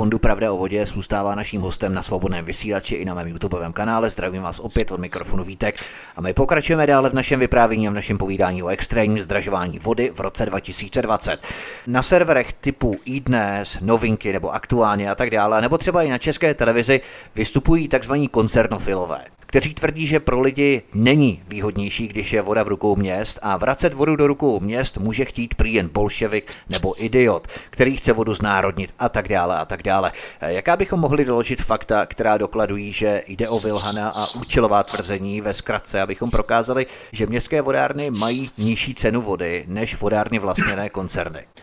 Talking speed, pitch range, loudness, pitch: 175 wpm, 100-125 Hz, -20 LUFS, 110 Hz